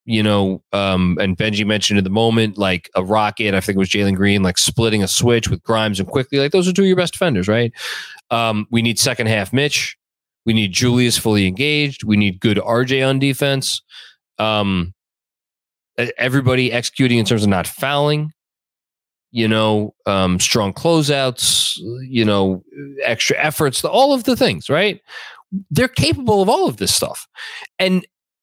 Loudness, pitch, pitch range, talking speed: -17 LUFS, 115 Hz, 105-140 Hz, 175 wpm